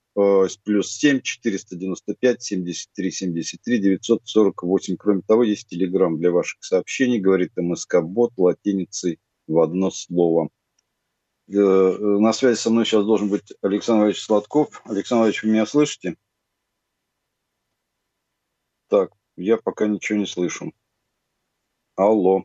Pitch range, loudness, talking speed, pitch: 95-110 Hz, -21 LUFS, 130 wpm, 100 Hz